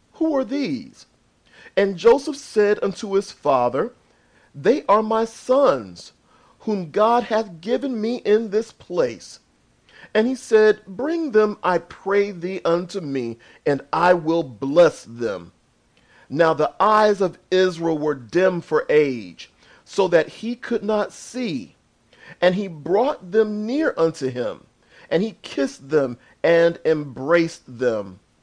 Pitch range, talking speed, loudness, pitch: 170-230 Hz, 135 wpm, -21 LUFS, 200 Hz